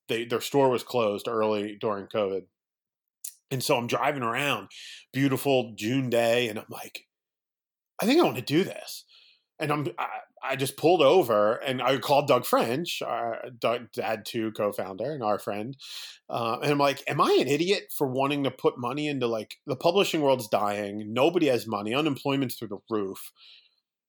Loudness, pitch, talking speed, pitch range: -27 LUFS, 125 Hz, 180 wpm, 110-140 Hz